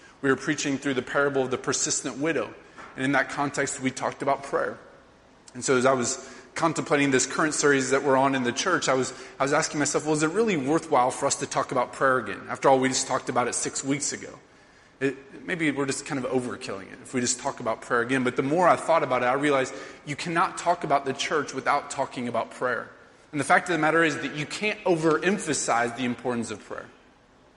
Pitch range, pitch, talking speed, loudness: 130-150 Hz, 140 Hz, 240 wpm, -25 LUFS